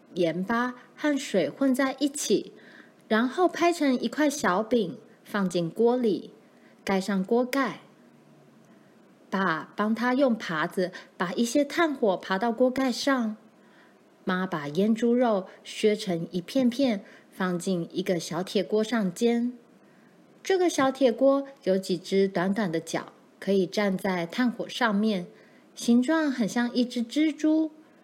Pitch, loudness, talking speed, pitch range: 225 Hz, -26 LUFS, 185 characters per minute, 190-265 Hz